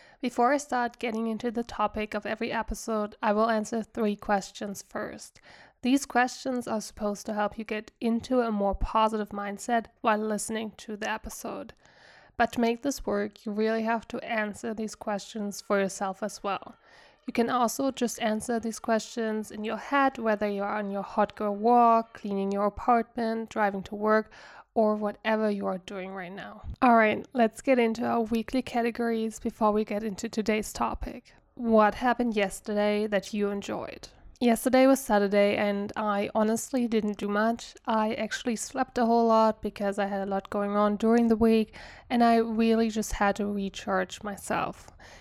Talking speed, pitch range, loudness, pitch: 175 wpm, 205-235 Hz, -28 LUFS, 220 Hz